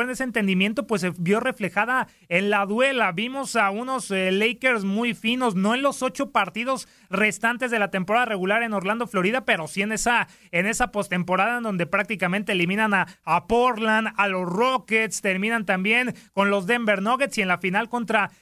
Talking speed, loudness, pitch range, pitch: 190 wpm, -23 LUFS, 195-240 Hz, 215 Hz